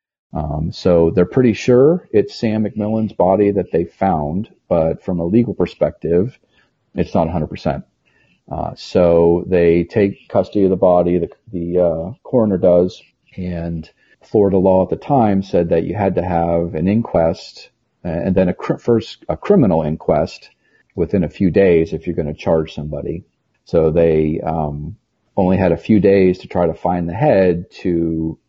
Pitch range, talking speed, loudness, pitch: 85-100 Hz, 170 wpm, -16 LUFS, 90 Hz